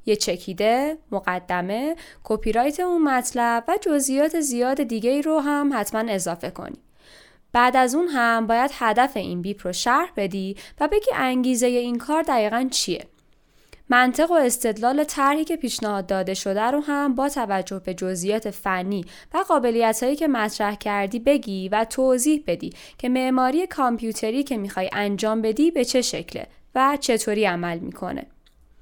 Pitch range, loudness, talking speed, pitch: 205-280 Hz, -22 LUFS, 155 wpm, 240 Hz